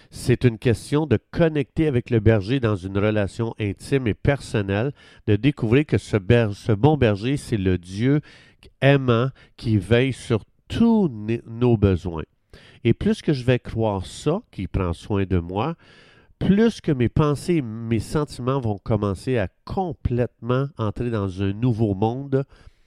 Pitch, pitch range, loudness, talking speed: 115 Hz, 105-135 Hz, -22 LUFS, 155 wpm